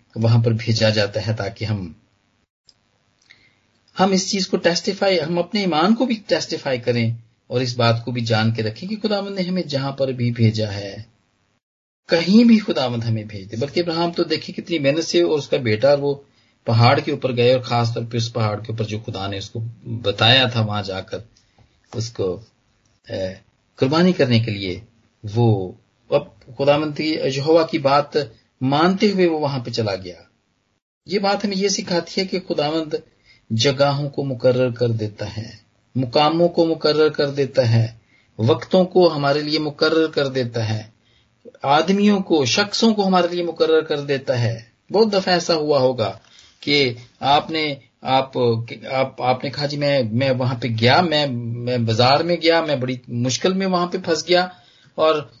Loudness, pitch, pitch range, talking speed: -19 LUFS, 130 Hz, 115-160 Hz, 170 wpm